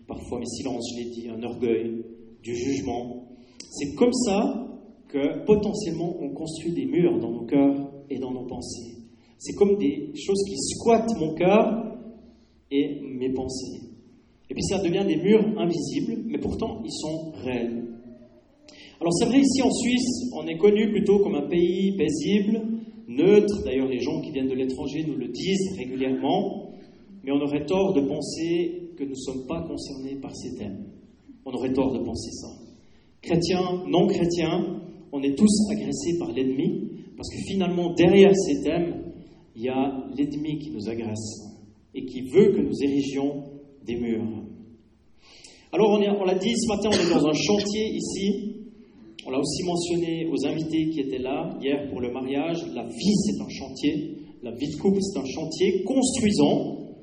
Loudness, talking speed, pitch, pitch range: -25 LUFS, 175 wpm, 155 Hz, 130-200 Hz